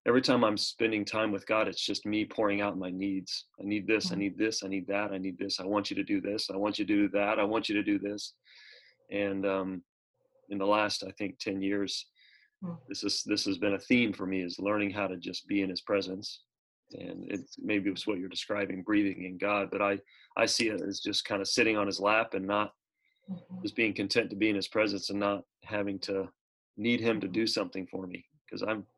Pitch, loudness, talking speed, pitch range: 100 Hz, -31 LUFS, 240 wpm, 100-110 Hz